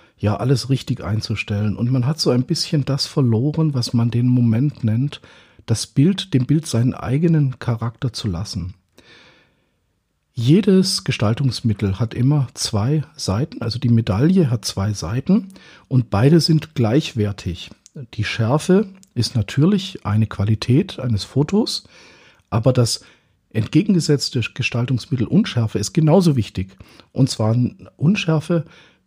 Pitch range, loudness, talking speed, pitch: 110-150 Hz, -19 LUFS, 125 wpm, 125 Hz